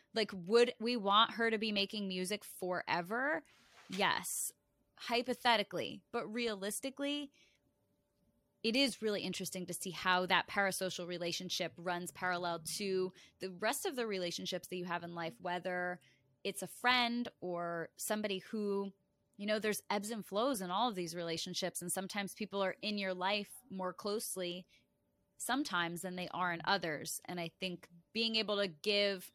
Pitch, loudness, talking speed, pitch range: 190 Hz, -37 LUFS, 155 wpm, 180-220 Hz